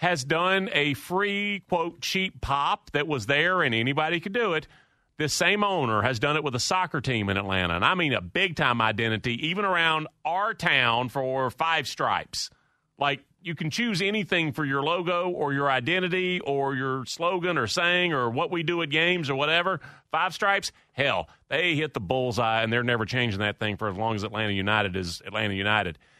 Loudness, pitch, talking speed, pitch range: -25 LUFS, 145 Hz, 200 wpm, 120-175 Hz